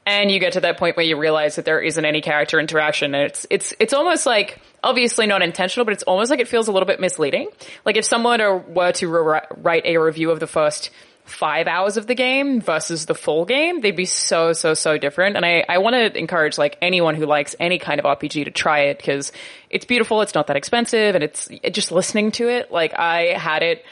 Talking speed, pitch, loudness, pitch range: 240 wpm, 175 Hz, -18 LUFS, 155-220 Hz